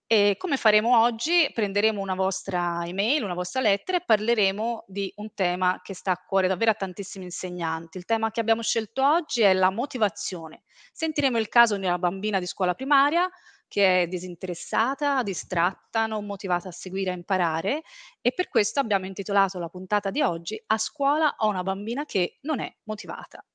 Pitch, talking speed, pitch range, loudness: 205 Hz, 180 wpm, 185-235 Hz, -25 LUFS